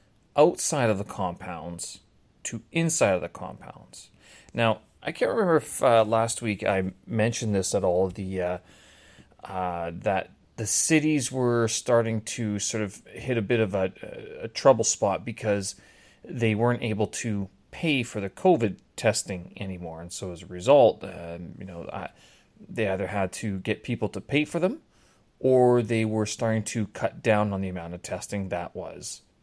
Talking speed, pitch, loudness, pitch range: 175 wpm, 105 Hz, -26 LUFS, 95-115 Hz